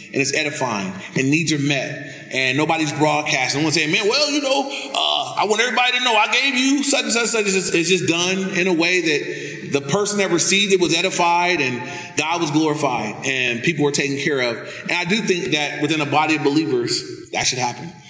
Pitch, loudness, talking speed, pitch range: 170 Hz, -18 LUFS, 235 wpm, 150-200 Hz